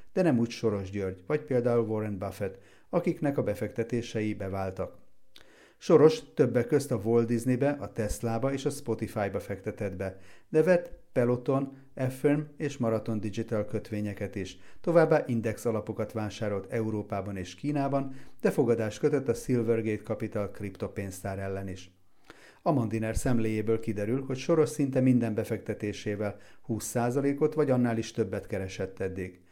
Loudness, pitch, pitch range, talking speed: -30 LUFS, 110 Hz, 100-130 Hz, 135 wpm